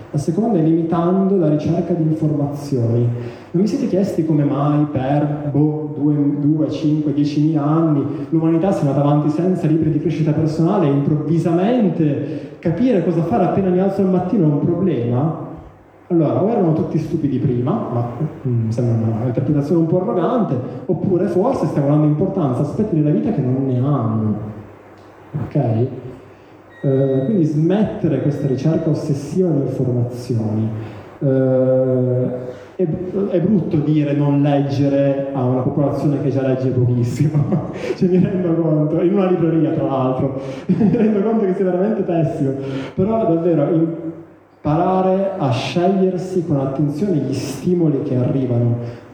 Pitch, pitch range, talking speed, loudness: 150 Hz, 135-170 Hz, 150 wpm, -18 LUFS